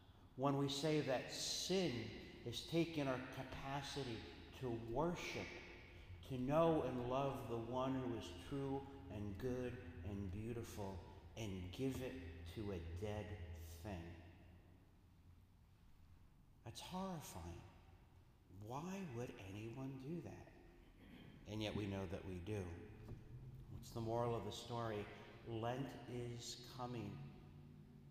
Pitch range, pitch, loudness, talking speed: 90-130 Hz, 115 Hz, -46 LUFS, 115 wpm